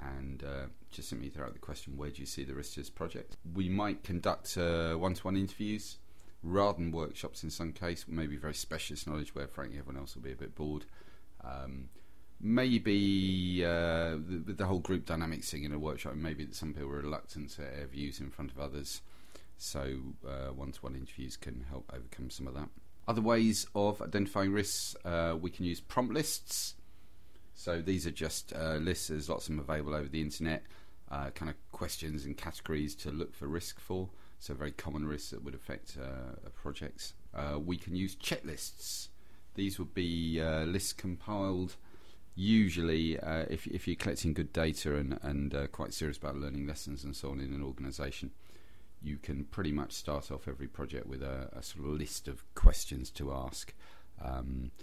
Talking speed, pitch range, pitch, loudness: 195 wpm, 70-90 Hz, 80 Hz, -37 LUFS